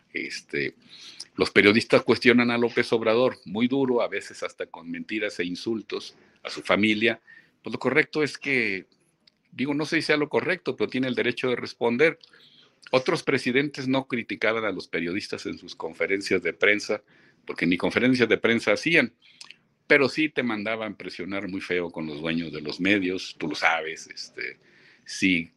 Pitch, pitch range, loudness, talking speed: 115 Hz, 95-140 Hz, -25 LUFS, 170 wpm